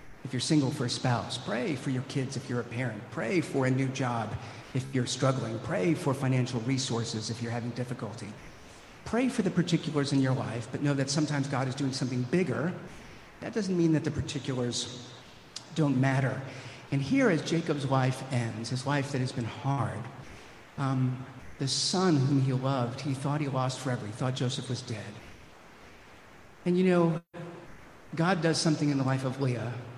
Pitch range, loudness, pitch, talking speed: 125-150 Hz, -30 LUFS, 135 Hz, 185 wpm